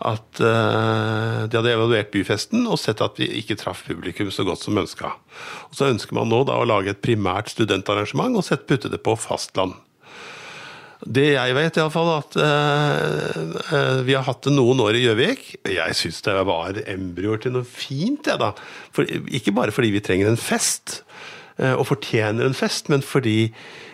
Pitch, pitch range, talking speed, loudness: 120 Hz, 105-145 Hz, 175 wpm, -21 LUFS